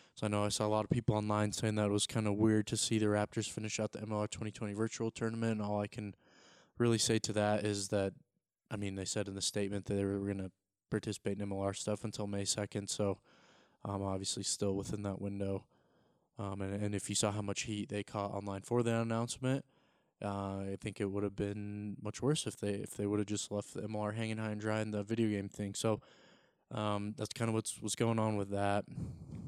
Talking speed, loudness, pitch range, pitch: 240 wpm, -37 LUFS, 100-110 Hz, 105 Hz